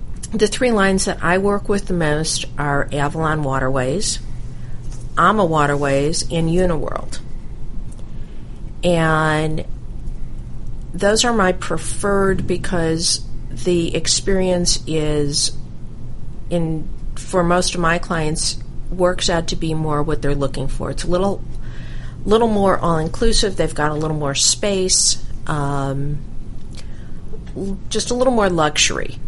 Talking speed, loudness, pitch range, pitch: 120 wpm, -18 LUFS, 135-185 Hz, 160 Hz